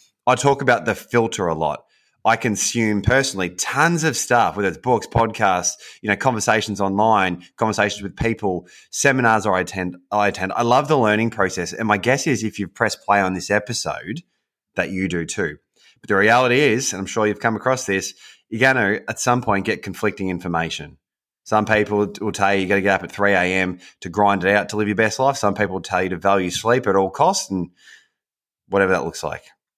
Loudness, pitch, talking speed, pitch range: -19 LUFS, 105 Hz, 210 wpm, 95-115 Hz